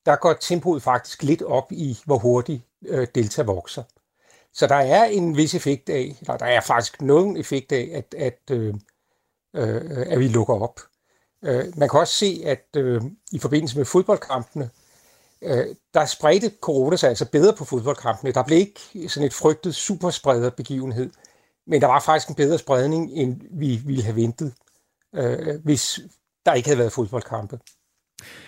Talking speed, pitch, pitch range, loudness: 160 wpm, 140 Hz, 125-155 Hz, -22 LUFS